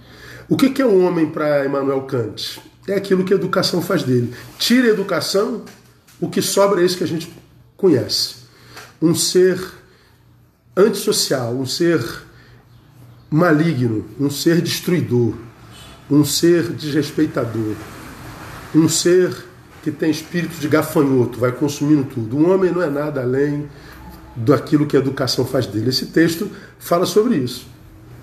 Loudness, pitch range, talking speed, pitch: -18 LUFS, 130-175 Hz, 145 wpm, 150 Hz